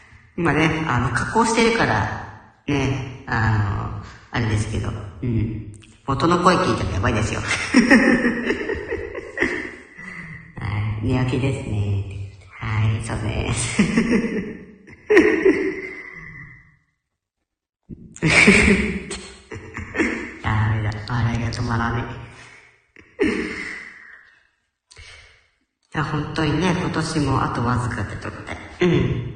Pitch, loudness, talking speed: 125 Hz, -21 LUFS, 185 characters per minute